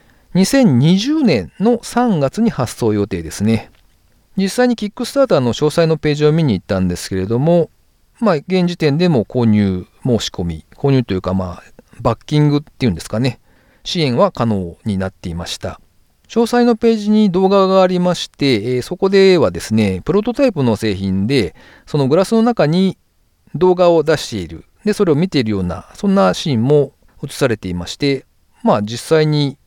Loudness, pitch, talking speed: -16 LUFS, 145 Hz, 340 characters per minute